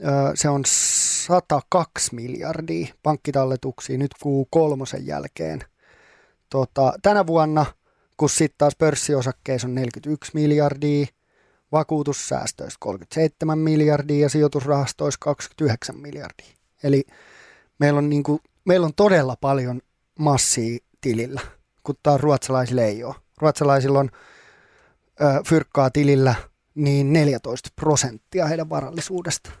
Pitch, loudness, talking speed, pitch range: 145 Hz, -21 LUFS, 105 wpm, 130-155 Hz